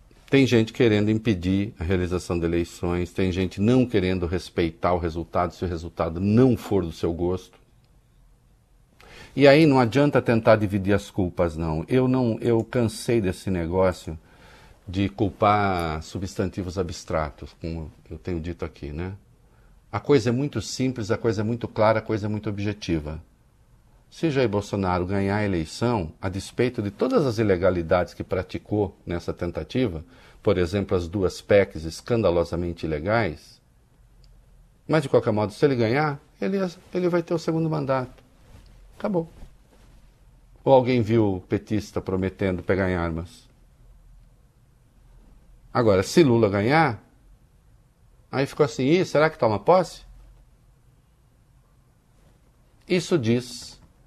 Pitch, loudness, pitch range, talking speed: 105 Hz, -24 LUFS, 90-125 Hz, 135 wpm